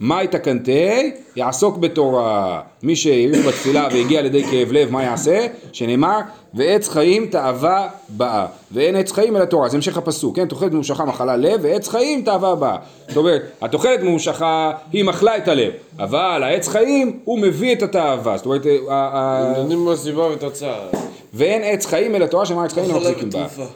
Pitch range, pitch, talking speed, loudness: 140-200 Hz, 170 Hz, 155 wpm, -18 LUFS